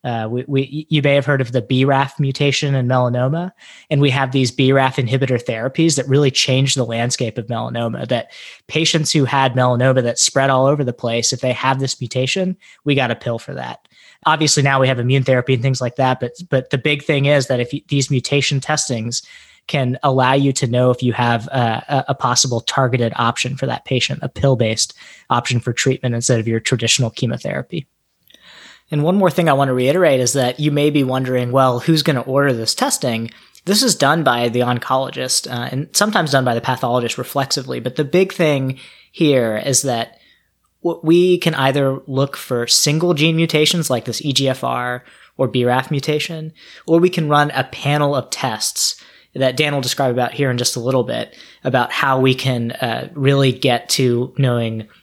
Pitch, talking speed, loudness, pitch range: 135 Hz, 195 wpm, -17 LUFS, 125-145 Hz